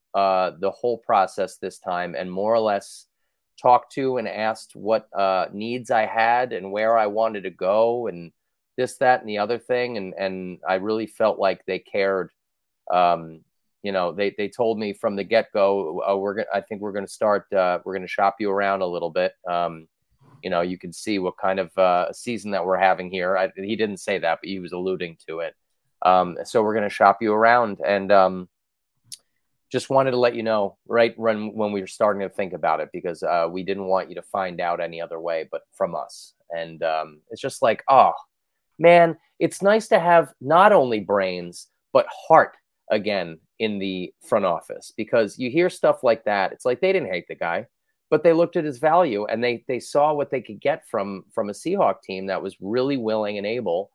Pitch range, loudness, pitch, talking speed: 95-115 Hz, -22 LUFS, 100 Hz, 215 wpm